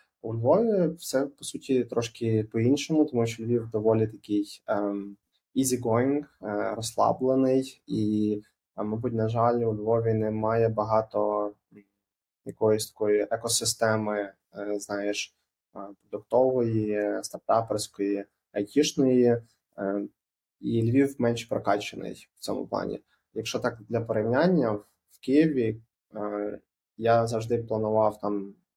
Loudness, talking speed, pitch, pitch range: -27 LUFS, 95 wpm, 110 Hz, 105-120 Hz